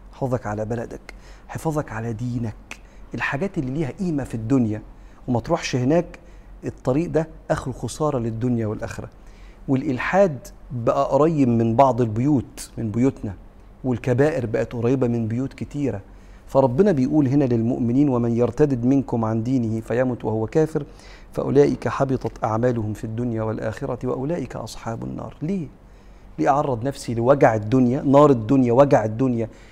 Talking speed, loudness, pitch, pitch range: 135 wpm, -22 LUFS, 125 Hz, 115-140 Hz